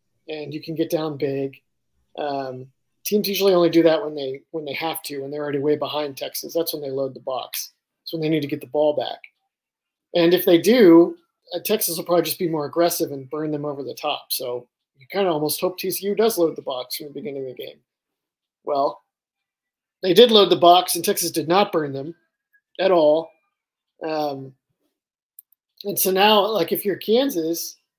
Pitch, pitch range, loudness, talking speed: 165 Hz, 145-185 Hz, -21 LUFS, 205 wpm